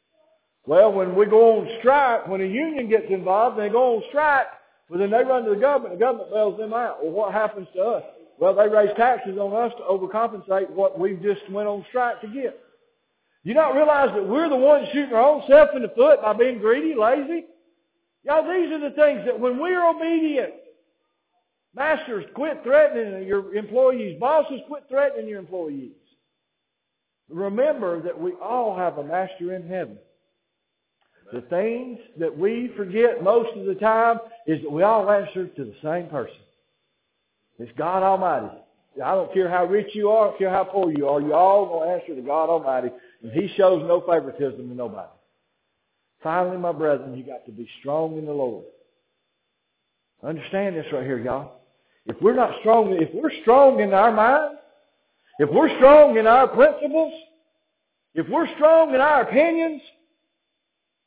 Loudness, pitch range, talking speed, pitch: -20 LUFS, 185-290 Hz, 180 wpm, 225 Hz